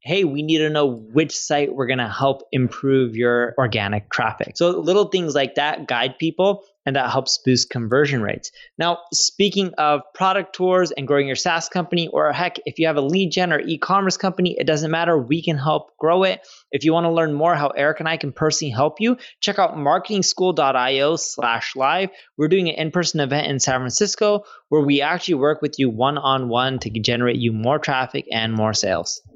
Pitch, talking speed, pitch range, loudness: 155 Hz, 195 wpm, 135-180 Hz, -20 LUFS